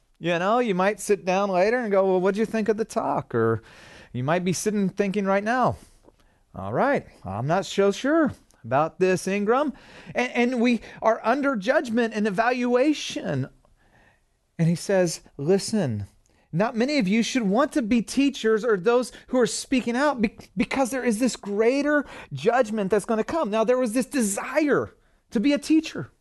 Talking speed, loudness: 185 wpm, -24 LUFS